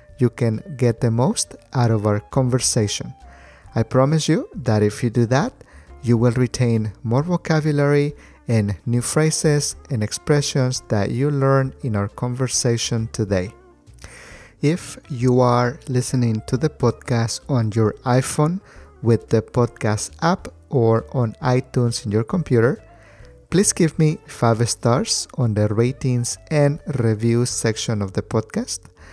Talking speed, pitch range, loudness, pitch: 140 wpm, 110-135 Hz, -20 LUFS, 120 Hz